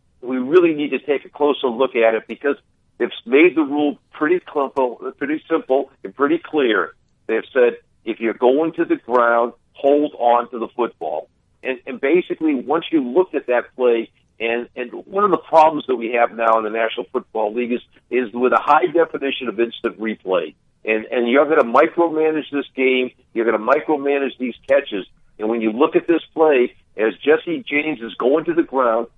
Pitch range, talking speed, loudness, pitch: 120-160 Hz, 200 wpm, -19 LUFS, 135 Hz